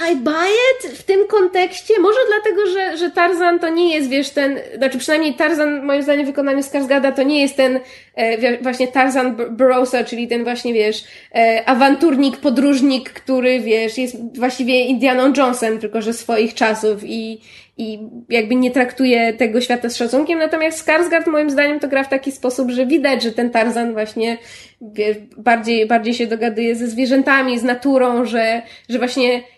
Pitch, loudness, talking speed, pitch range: 255 Hz, -16 LUFS, 175 wpm, 235-285 Hz